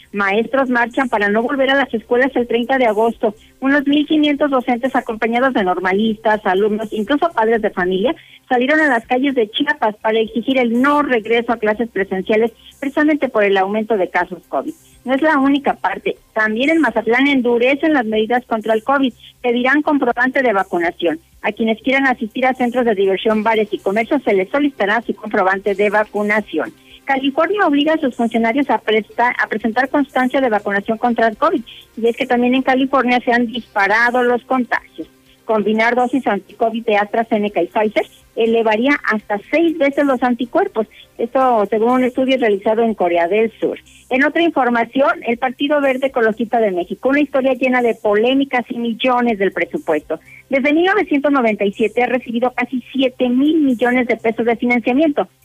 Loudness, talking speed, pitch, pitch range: -16 LUFS, 170 wpm, 240 Hz, 220-270 Hz